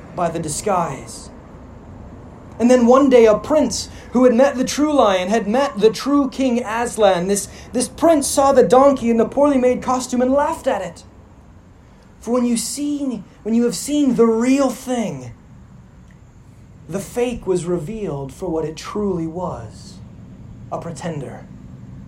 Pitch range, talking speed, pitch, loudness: 170-255 Hz, 160 wpm, 230 Hz, -17 LUFS